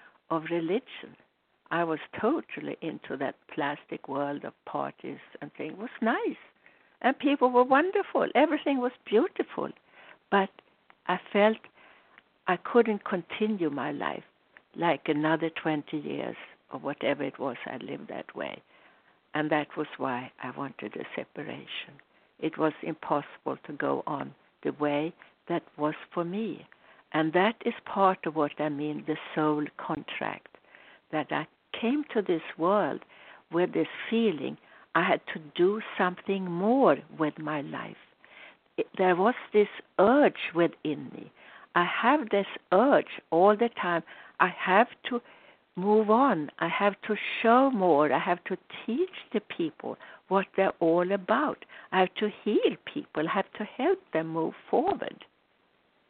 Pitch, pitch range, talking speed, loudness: 190 Hz, 160-230 Hz, 145 wpm, -29 LUFS